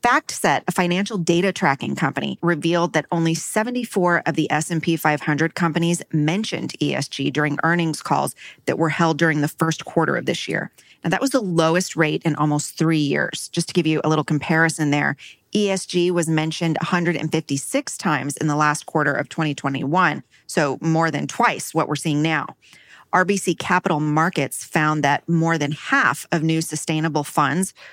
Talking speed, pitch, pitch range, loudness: 170 wpm, 165 Hz, 150-175 Hz, -21 LUFS